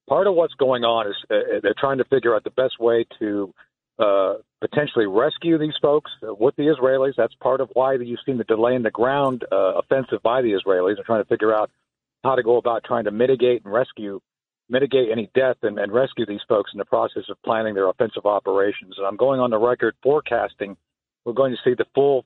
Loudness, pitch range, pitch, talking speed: -21 LUFS, 115-135 Hz, 125 Hz, 220 wpm